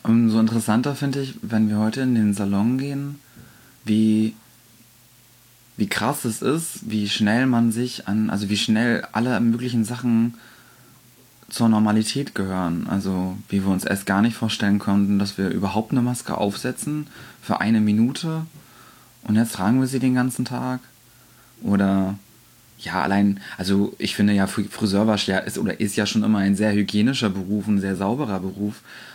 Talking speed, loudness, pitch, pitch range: 160 wpm, -22 LUFS, 110 Hz, 100-125 Hz